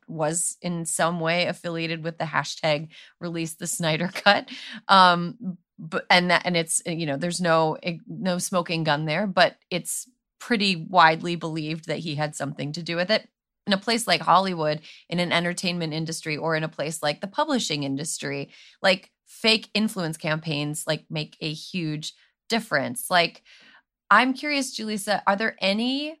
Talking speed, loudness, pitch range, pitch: 165 wpm, -24 LUFS, 160-200 Hz, 170 Hz